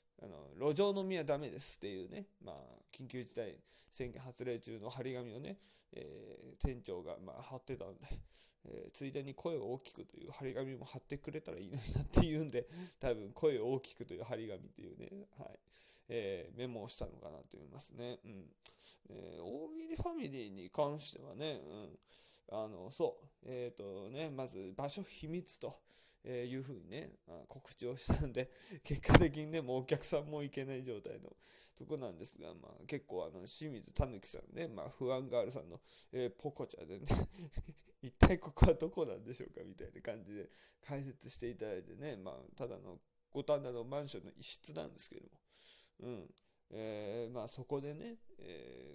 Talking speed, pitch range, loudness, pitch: 340 characters per minute, 125-160 Hz, -40 LUFS, 135 Hz